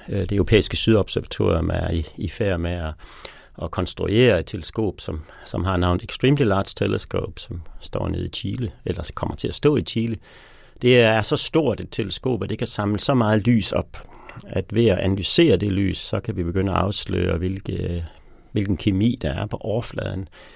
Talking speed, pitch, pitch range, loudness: 190 wpm, 100 Hz, 90-110 Hz, -22 LUFS